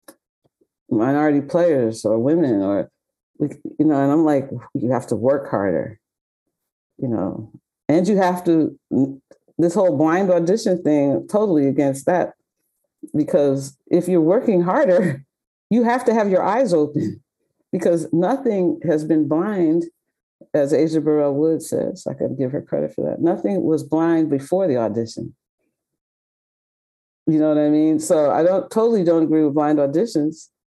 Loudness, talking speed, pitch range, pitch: -19 LUFS, 155 wpm, 150-180 Hz, 160 Hz